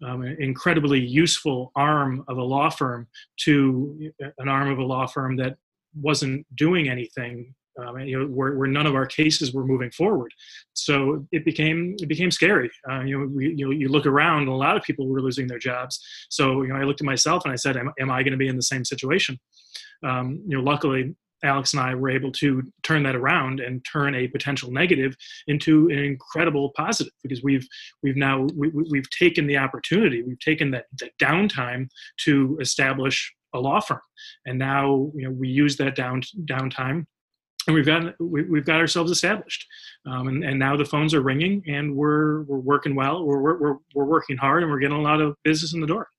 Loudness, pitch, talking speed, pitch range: -23 LUFS, 140 Hz, 210 wpm, 130-155 Hz